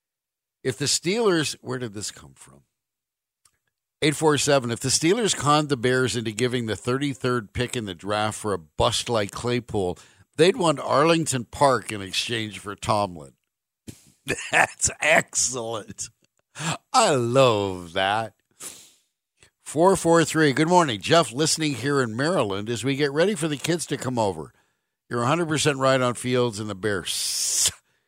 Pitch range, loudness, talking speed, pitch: 110-150 Hz, -23 LUFS, 145 wpm, 125 Hz